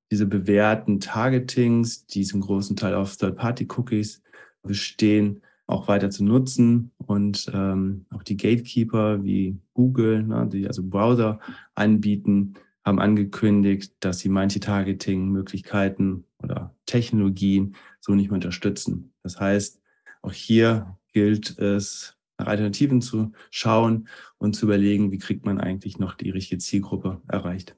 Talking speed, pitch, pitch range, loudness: 130 wpm, 100 Hz, 95-110 Hz, -23 LUFS